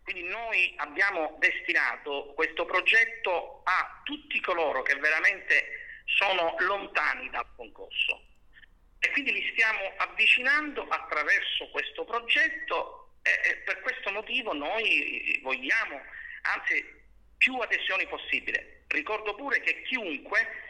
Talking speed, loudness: 105 wpm, -27 LUFS